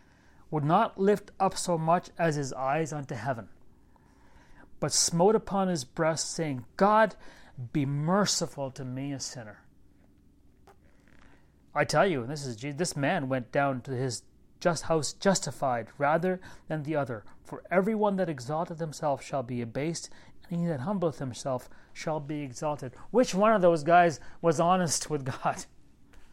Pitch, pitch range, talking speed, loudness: 150 Hz, 135-175 Hz, 155 wpm, -29 LUFS